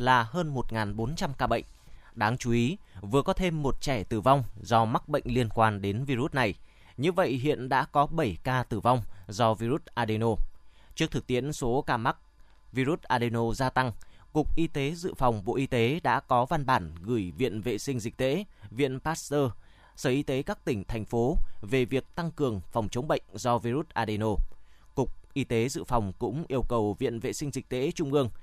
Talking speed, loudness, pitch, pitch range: 205 wpm, -29 LUFS, 125 Hz, 110-140 Hz